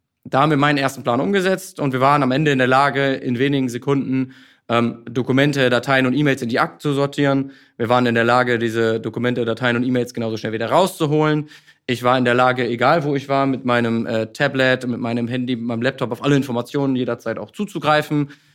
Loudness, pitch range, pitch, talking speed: -19 LUFS, 120-140 Hz, 130 Hz, 215 wpm